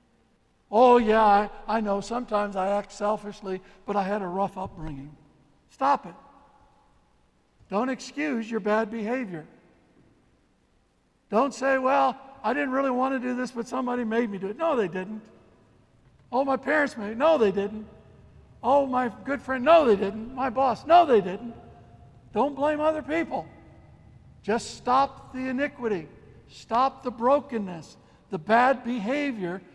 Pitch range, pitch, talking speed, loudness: 200-265 Hz, 230 Hz, 150 wpm, -25 LUFS